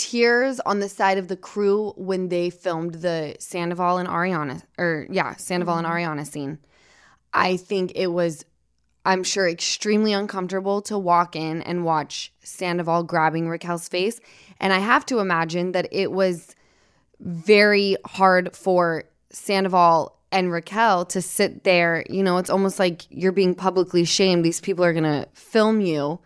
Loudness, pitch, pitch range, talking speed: -22 LUFS, 180 Hz, 170-195 Hz, 160 wpm